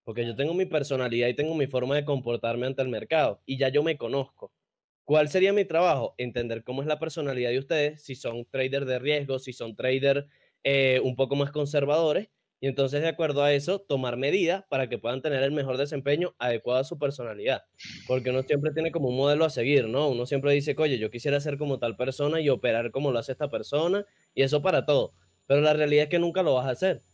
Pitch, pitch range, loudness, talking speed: 140 Hz, 130-150 Hz, -27 LUFS, 230 wpm